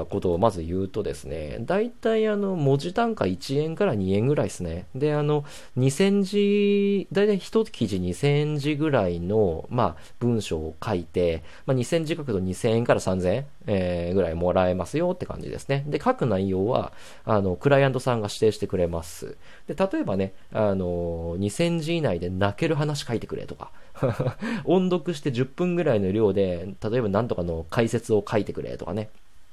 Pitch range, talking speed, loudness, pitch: 95-160 Hz, 310 characters per minute, -25 LUFS, 115 Hz